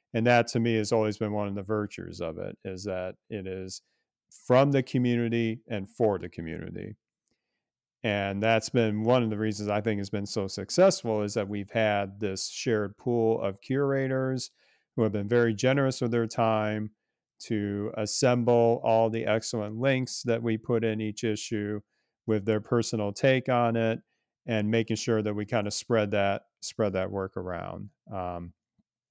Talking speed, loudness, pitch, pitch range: 175 wpm, -28 LUFS, 110 Hz, 105-120 Hz